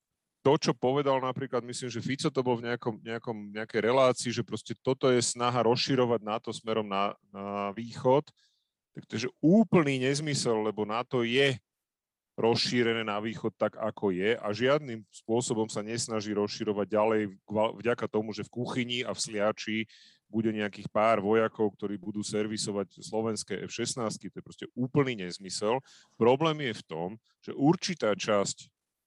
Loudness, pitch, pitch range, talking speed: -30 LUFS, 115 Hz, 105-125 Hz, 155 wpm